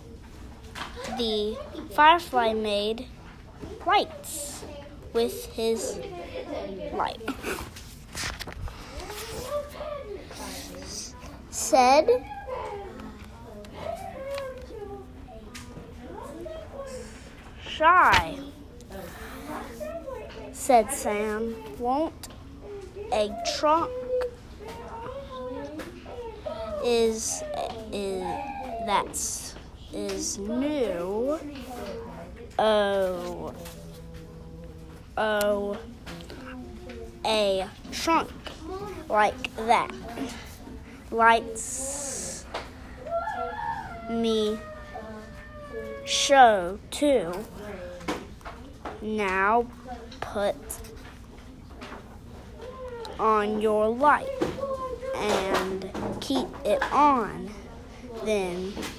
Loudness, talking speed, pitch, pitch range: -27 LUFS, 40 wpm, 230 Hz, 205-315 Hz